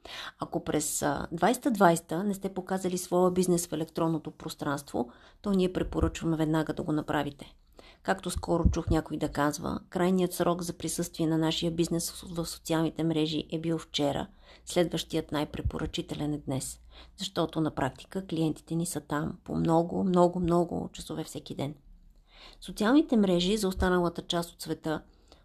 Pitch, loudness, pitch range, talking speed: 165 Hz, -30 LUFS, 155-180 Hz, 145 wpm